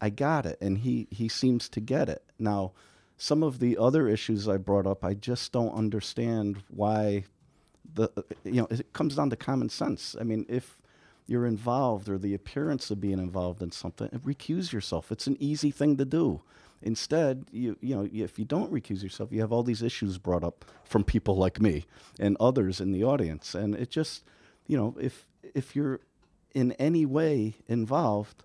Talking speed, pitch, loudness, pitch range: 190 wpm, 110 Hz, -29 LUFS, 100-130 Hz